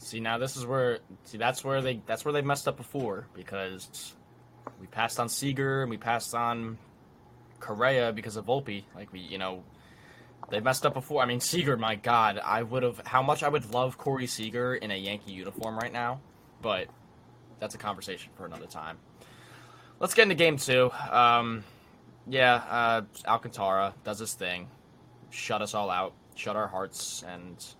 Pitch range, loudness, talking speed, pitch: 105-130 Hz, -29 LUFS, 180 wpm, 120 Hz